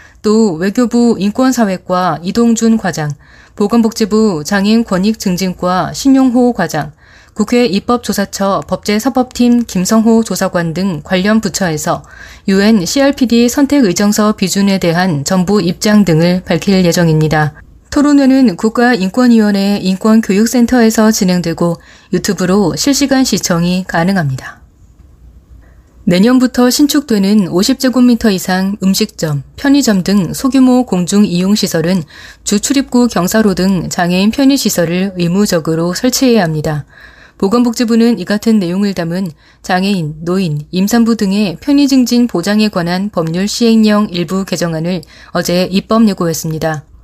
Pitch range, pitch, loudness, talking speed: 180-230 Hz, 200 Hz, -12 LUFS, 300 characters per minute